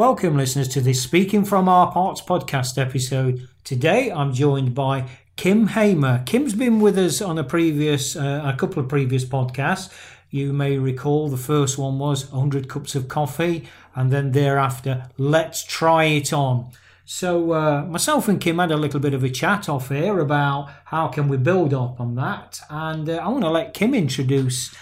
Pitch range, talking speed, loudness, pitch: 135-165 Hz, 185 wpm, -21 LUFS, 145 Hz